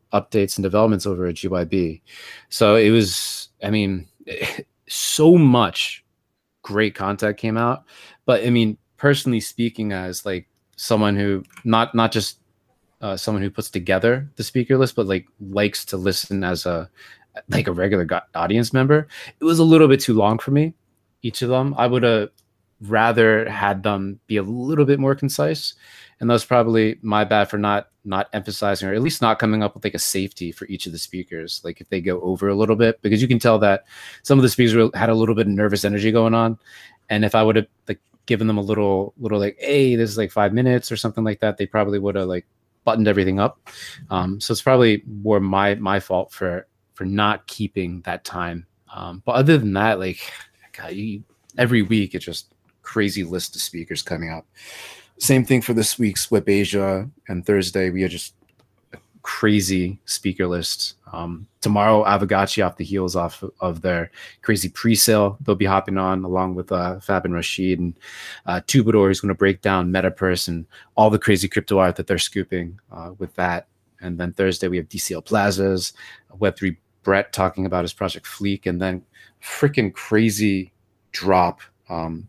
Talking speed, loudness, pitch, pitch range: 195 wpm, -20 LUFS, 100 Hz, 95-115 Hz